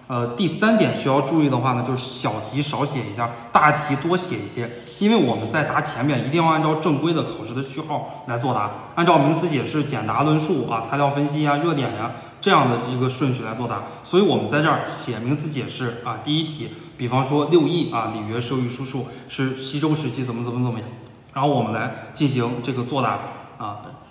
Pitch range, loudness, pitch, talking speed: 120-155 Hz, -22 LUFS, 135 Hz, 325 characters per minute